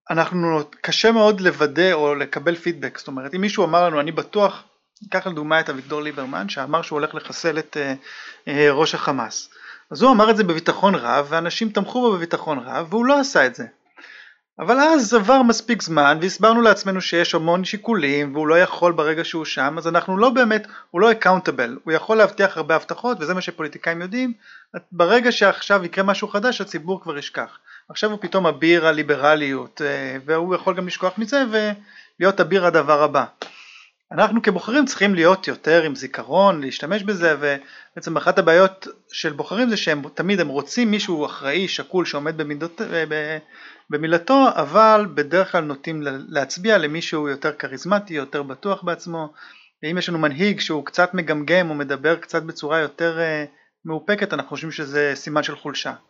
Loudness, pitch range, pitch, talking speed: -19 LUFS, 150-200 Hz, 170 Hz, 165 wpm